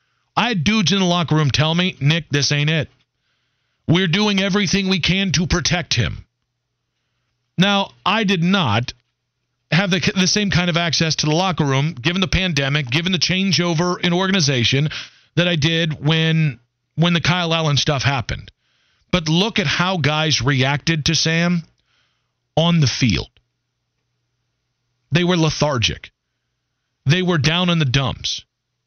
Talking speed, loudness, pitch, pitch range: 155 wpm, -18 LUFS, 155 Hz, 130-175 Hz